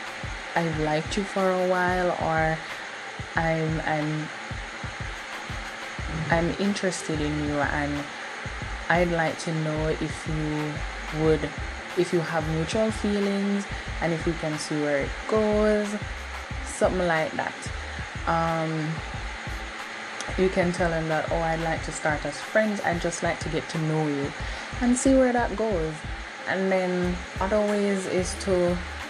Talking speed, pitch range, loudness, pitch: 145 wpm, 155-190 Hz, -27 LUFS, 165 Hz